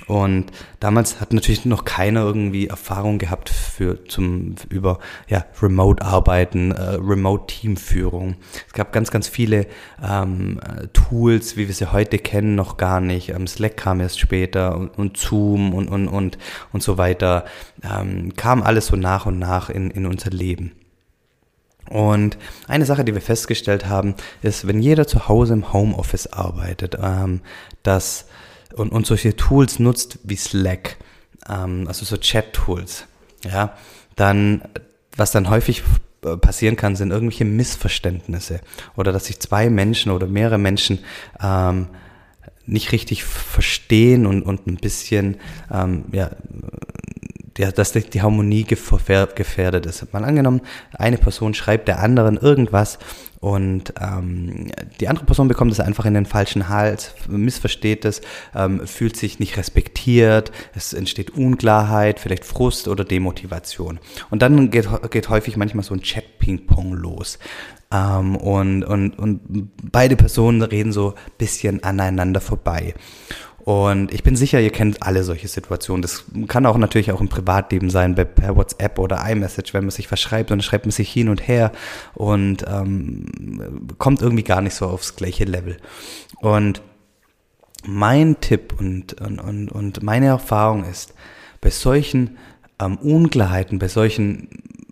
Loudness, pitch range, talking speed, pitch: -19 LUFS, 95-110 Hz, 145 wpm, 100 Hz